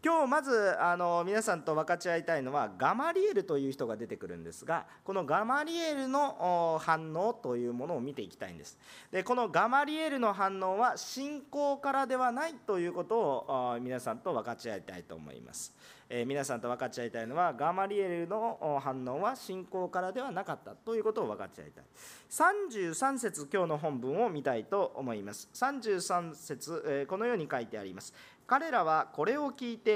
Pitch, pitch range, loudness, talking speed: 190 Hz, 155-255 Hz, -33 LUFS, 375 characters per minute